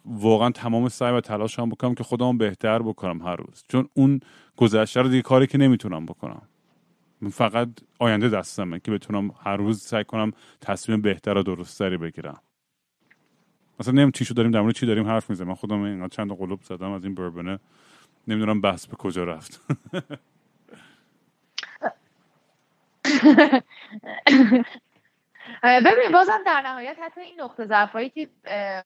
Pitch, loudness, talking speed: 120 Hz, -22 LUFS, 145 wpm